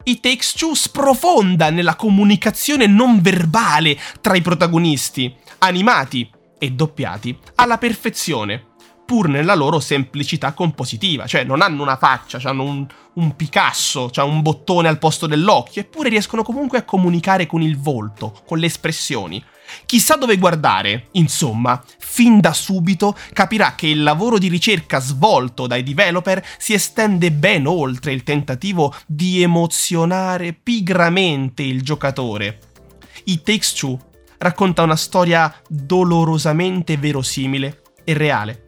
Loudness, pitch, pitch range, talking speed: -16 LUFS, 165 Hz, 140-195 Hz, 135 wpm